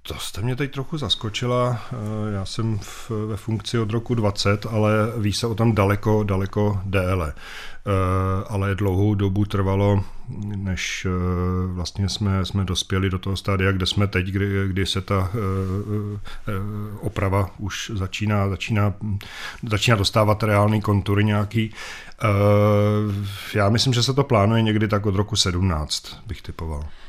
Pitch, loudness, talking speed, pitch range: 100 Hz, -22 LUFS, 150 wpm, 95-110 Hz